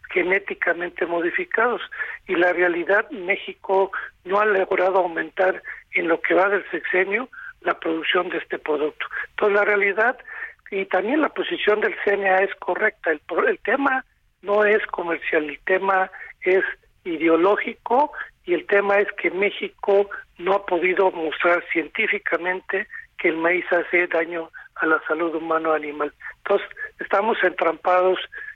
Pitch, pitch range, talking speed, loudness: 190 Hz, 175-210 Hz, 140 wpm, -22 LUFS